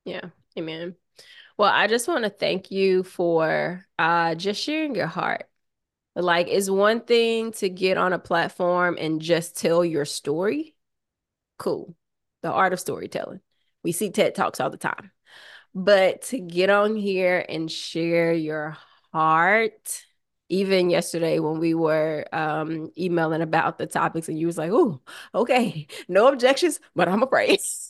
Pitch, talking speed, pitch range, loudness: 180 Hz, 155 wpm, 165-205 Hz, -23 LUFS